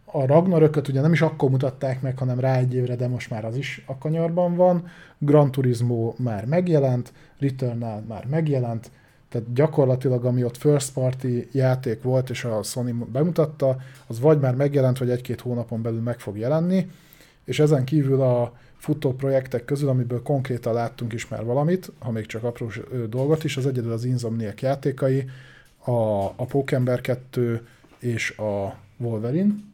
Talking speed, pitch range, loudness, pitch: 165 wpm, 120-145 Hz, -23 LUFS, 130 Hz